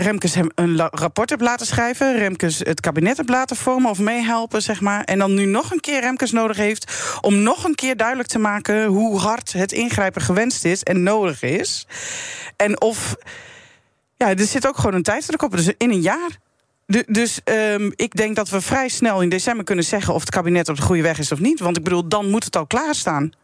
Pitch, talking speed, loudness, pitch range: 215 Hz, 225 wpm, -19 LUFS, 185-245 Hz